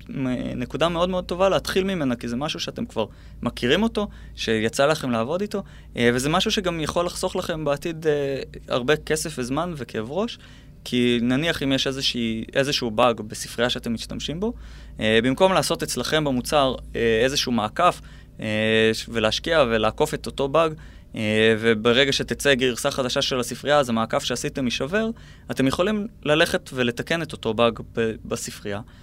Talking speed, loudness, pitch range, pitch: 145 wpm, -23 LUFS, 120-155 Hz, 135 Hz